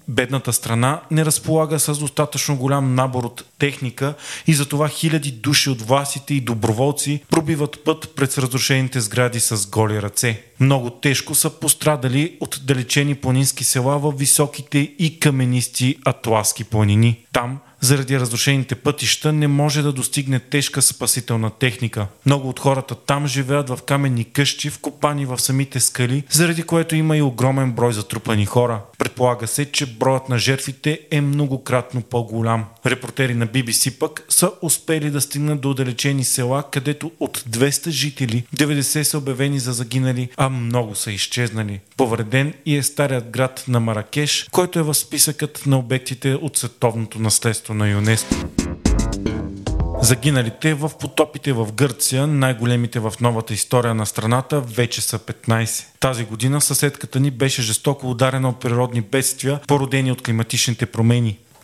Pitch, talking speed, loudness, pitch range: 135 Hz, 145 wpm, -19 LUFS, 120-145 Hz